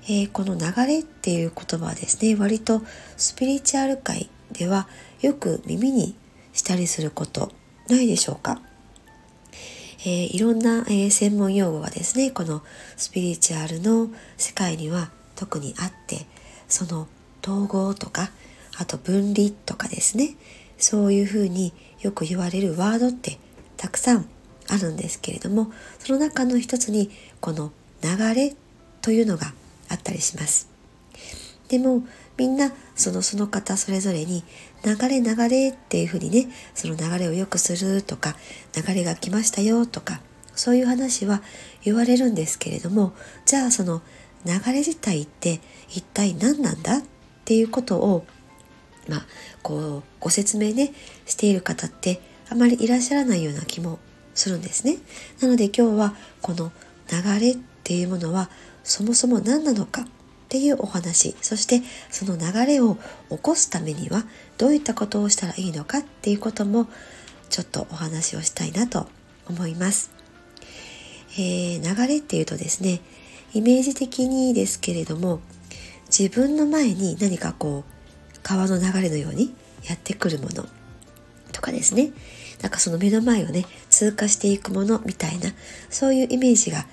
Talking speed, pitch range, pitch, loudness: 305 characters per minute, 175-240 Hz, 200 Hz, -23 LUFS